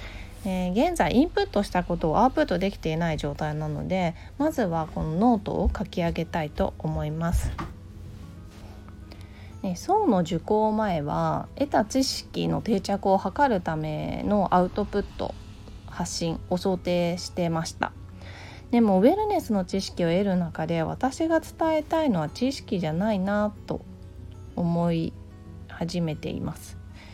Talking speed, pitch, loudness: 290 characters per minute, 170 Hz, -26 LUFS